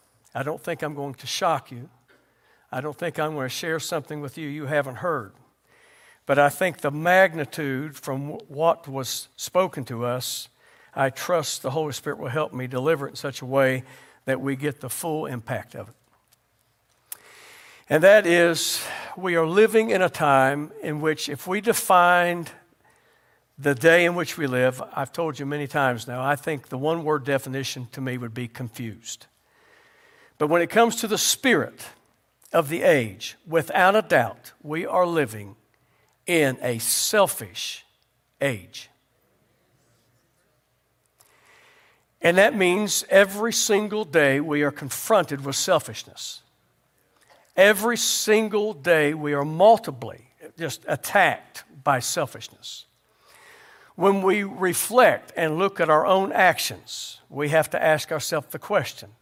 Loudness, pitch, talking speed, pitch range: -23 LUFS, 150 Hz, 150 wpm, 130-175 Hz